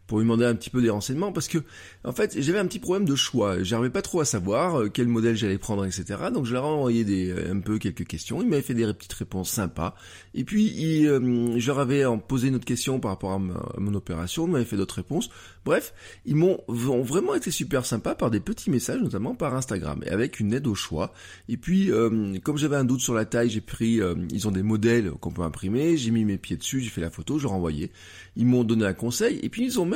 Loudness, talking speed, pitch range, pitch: -26 LUFS, 255 wpm, 100-140 Hz, 120 Hz